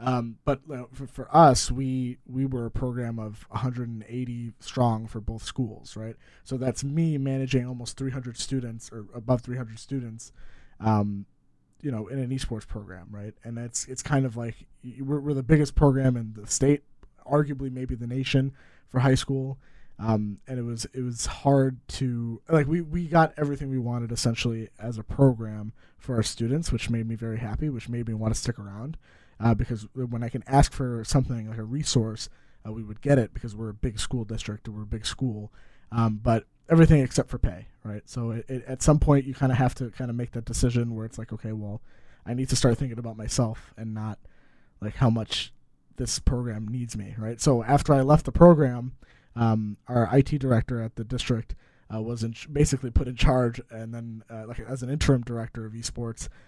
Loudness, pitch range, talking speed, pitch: -26 LUFS, 110-135 Hz, 210 wpm, 120 Hz